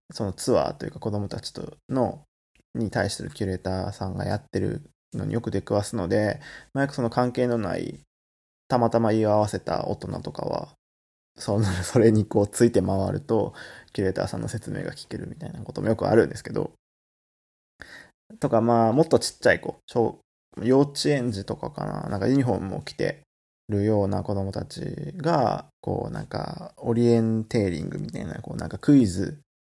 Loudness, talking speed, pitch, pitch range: -25 LUFS, 370 characters per minute, 110 Hz, 95-120 Hz